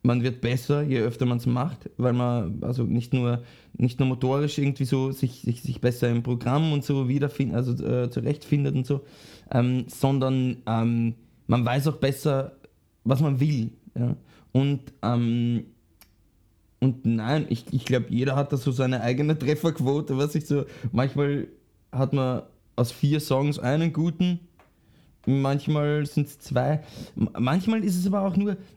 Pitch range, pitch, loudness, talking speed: 120-145 Hz, 130 Hz, -26 LUFS, 160 wpm